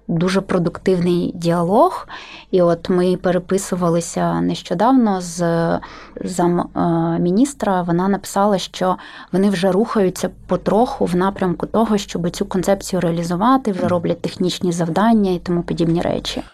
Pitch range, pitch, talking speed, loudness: 175-200 Hz, 185 Hz, 120 wpm, -18 LUFS